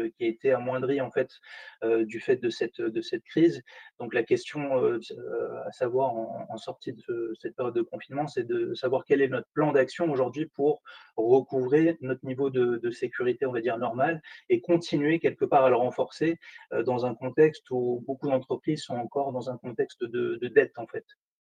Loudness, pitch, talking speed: -28 LUFS, 170 Hz, 205 wpm